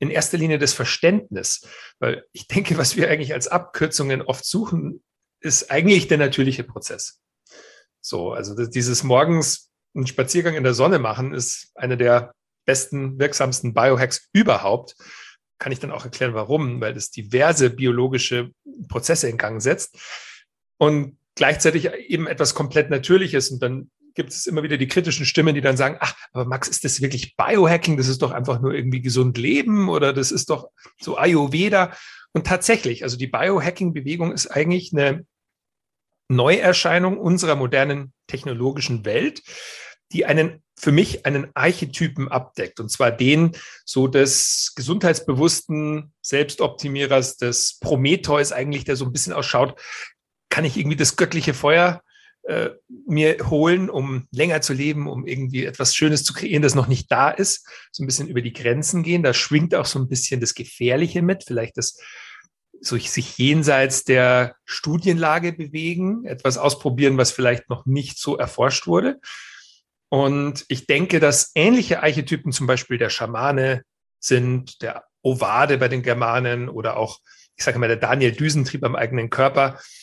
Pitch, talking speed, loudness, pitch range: 140 Hz, 155 wpm, -20 LUFS, 130-160 Hz